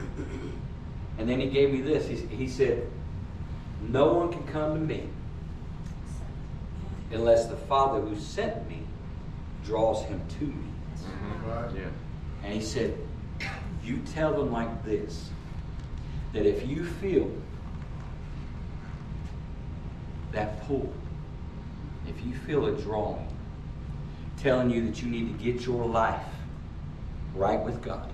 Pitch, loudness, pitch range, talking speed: 105 Hz, -31 LUFS, 80-115 Hz, 115 wpm